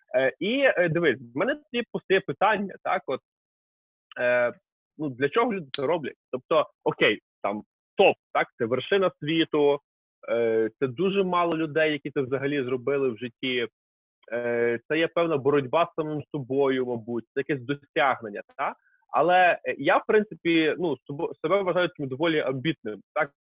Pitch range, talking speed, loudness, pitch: 130-180 Hz, 145 wpm, -26 LUFS, 150 Hz